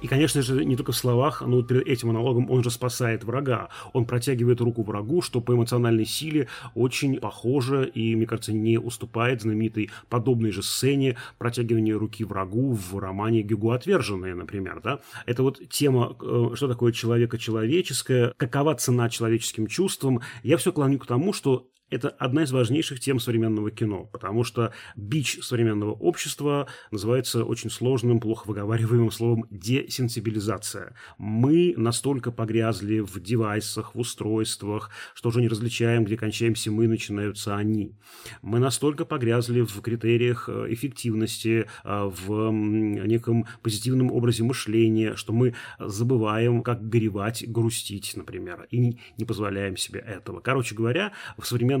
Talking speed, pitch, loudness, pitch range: 140 wpm, 115 Hz, -25 LUFS, 110-125 Hz